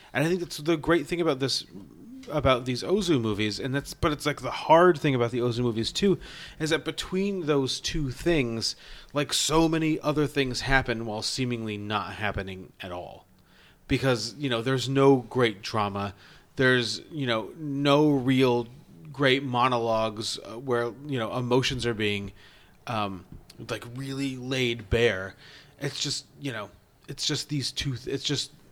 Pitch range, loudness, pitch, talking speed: 115-145 Hz, -26 LUFS, 130 Hz, 165 wpm